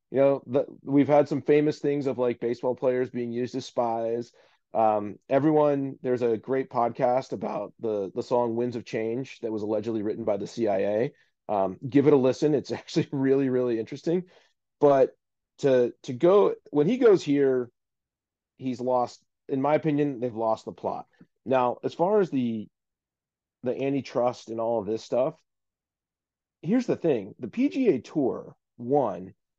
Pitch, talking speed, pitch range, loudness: 130 Hz, 165 wpm, 120-145 Hz, -26 LUFS